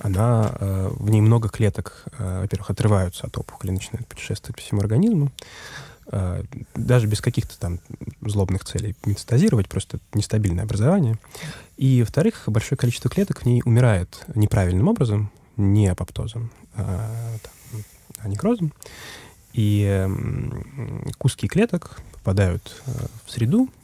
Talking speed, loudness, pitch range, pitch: 110 wpm, -23 LUFS, 100-125 Hz, 110 Hz